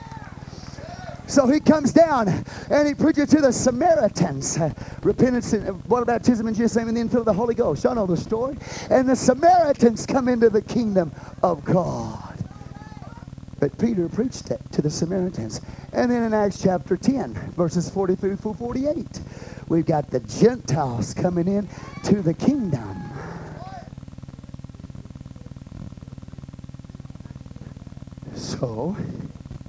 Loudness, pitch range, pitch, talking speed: -22 LUFS, 170-245 Hz, 215 Hz, 135 wpm